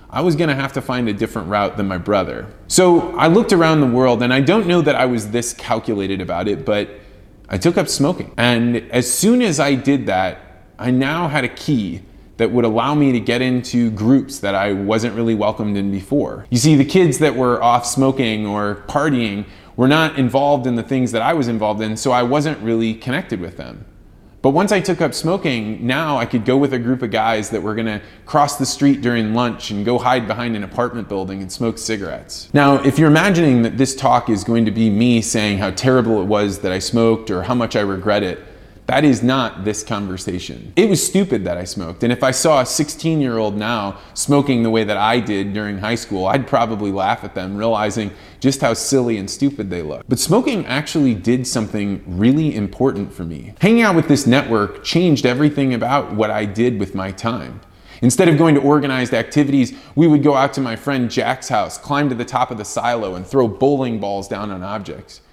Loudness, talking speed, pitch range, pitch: -17 LUFS, 220 wpm, 105-140 Hz, 120 Hz